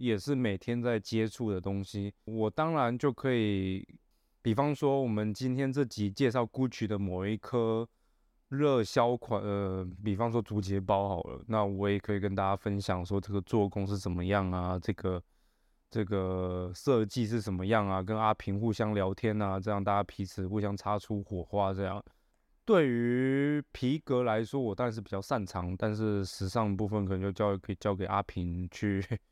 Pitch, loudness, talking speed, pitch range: 105 Hz, -32 LUFS, 270 characters per minute, 100-115 Hz